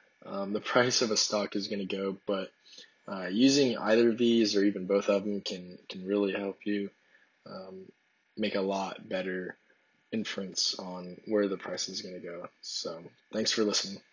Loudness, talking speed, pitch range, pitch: -30 LUFS, 185 wpm, 95-105 Hz, 100 Hz